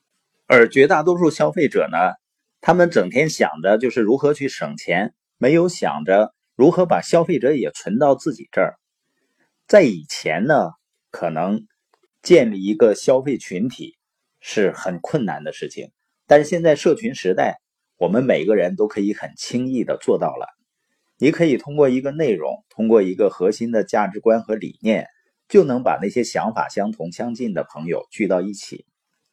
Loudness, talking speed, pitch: -19 LUFS, 250 characters per minute, 160 Hz